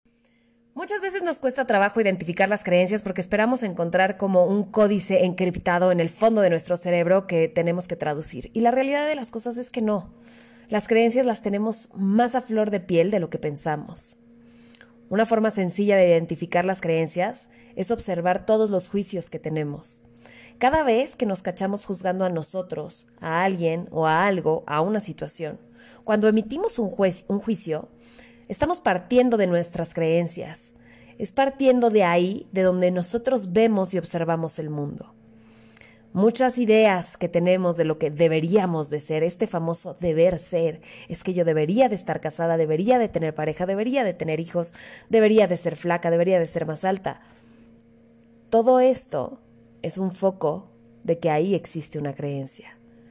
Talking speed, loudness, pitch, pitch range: 170 wpm, -23 LUFS, 185 Hz, 165-220 Hz